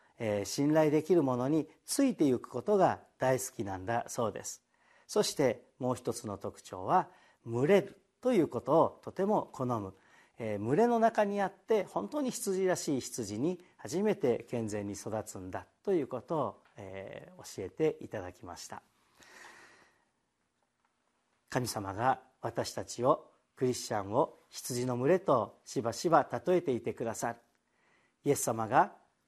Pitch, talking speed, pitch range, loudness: 130 Hz, 265 characters per minute, 110-185 Hz, -32 LUFS